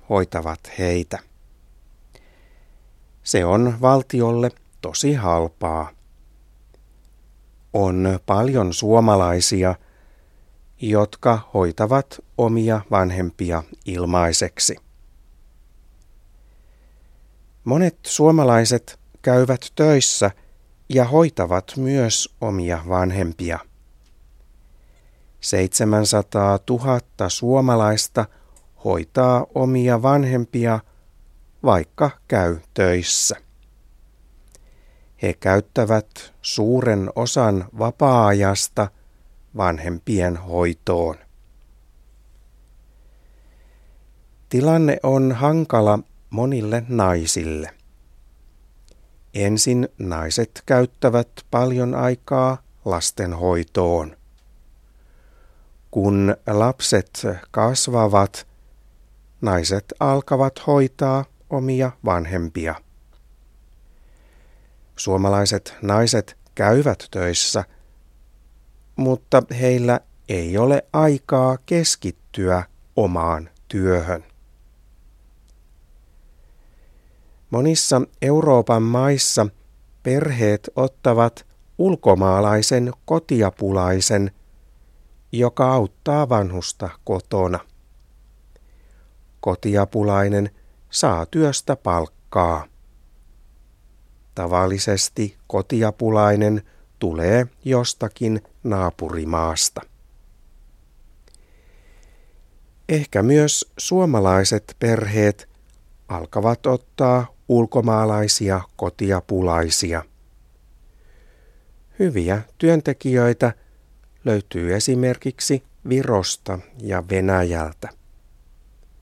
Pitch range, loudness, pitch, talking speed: 85-120 Hz, -20 LUFS, 100 Hz, 55 wpm